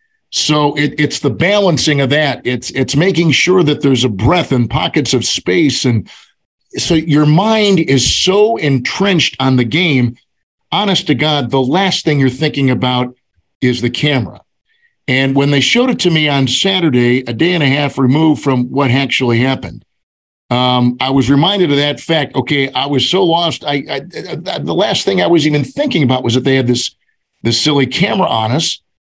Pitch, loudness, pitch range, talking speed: 140 Hz, -13 LUFS, 130-165 Hz, 190 wpm